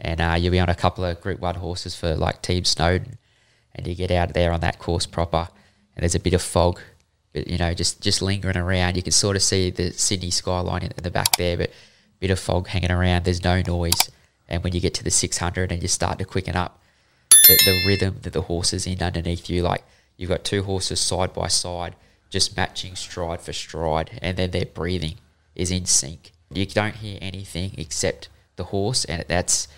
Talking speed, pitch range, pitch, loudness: 225 wpm, 85-95 Hz, 90 Hz, -21 LUFS